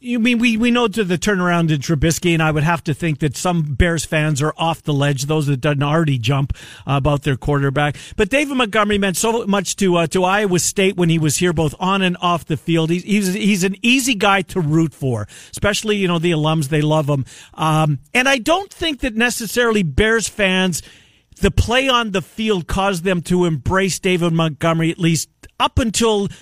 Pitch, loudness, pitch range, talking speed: 175 Hz, -17 LUFS, 155-205 Hz, 215 wpm